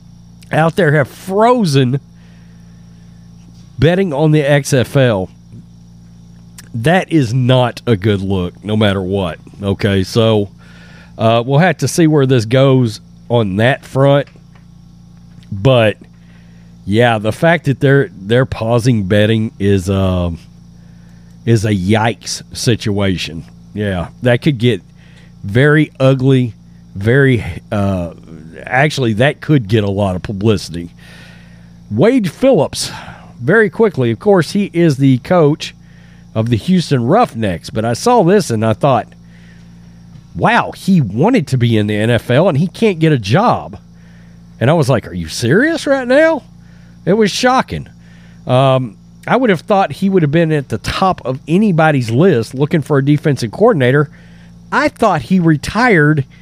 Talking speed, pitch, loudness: 140 wpm, 115 Hz, -13 LUFS